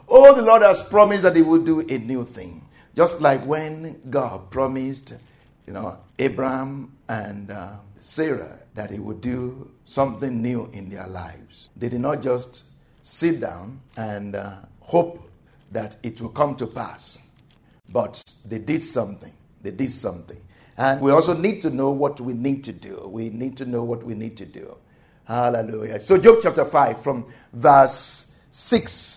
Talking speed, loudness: 170 wpm, -20 LUFS